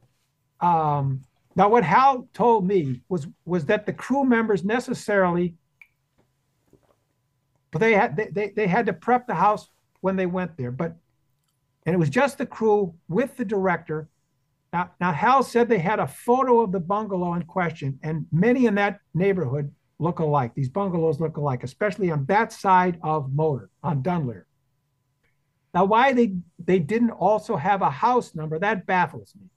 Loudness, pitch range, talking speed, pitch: -23 LUFS, 145-210 Hz, 165 wpm, 175 Hz